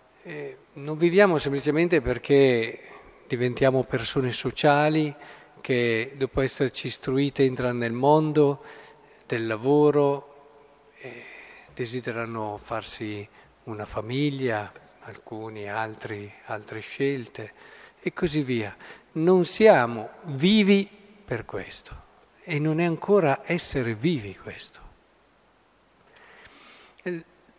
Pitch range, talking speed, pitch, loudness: 120-150 Hz, 85 wpm, 135 Hz, -24 LUFS